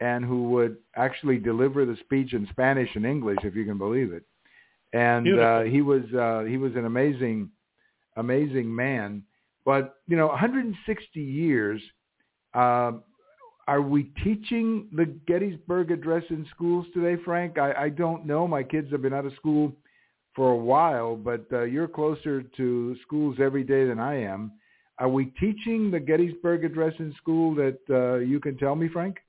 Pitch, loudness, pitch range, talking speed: 140 Hz, -26 LUFS, 125-165 Hz, 170 wpm